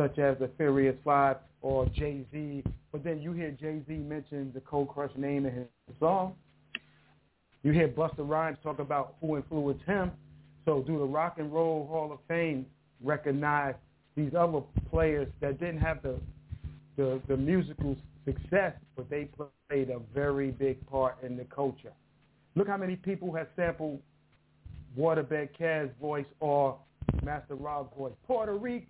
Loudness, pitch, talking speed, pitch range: -32 LUFS, 145 Hz, 155 wpm, 135-155 Hz